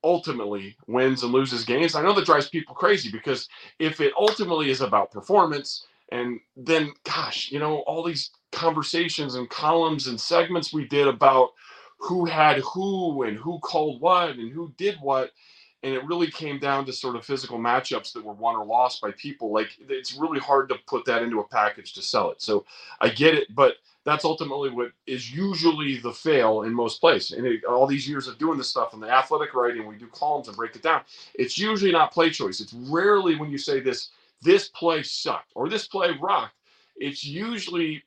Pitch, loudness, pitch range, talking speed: 150 Hz, -24 LUFS, 130-170 Hz, 205 wpm